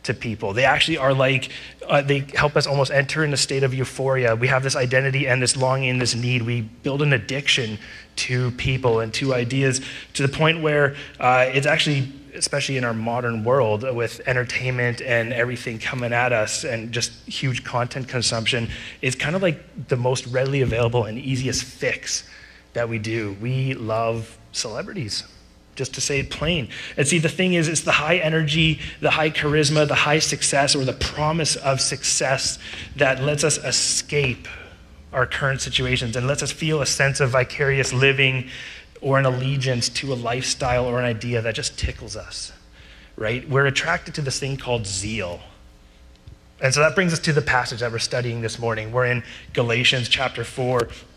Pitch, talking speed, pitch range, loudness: 130 Hz, 185 wpm, 120-140 Hz, -21 LUFS